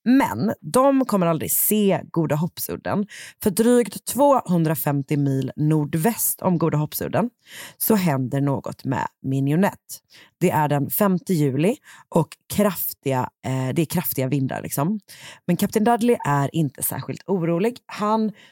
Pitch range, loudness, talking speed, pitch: 140-215 Hz, -22 LUFS, 130 wpm, 170 Hz